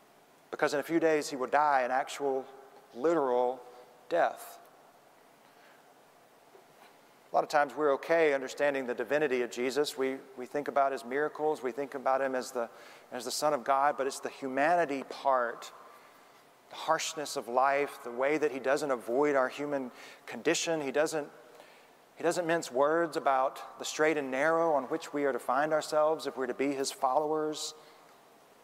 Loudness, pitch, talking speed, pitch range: -31 LUFS, 140 Hz, 170 wpm, 130-155 Hz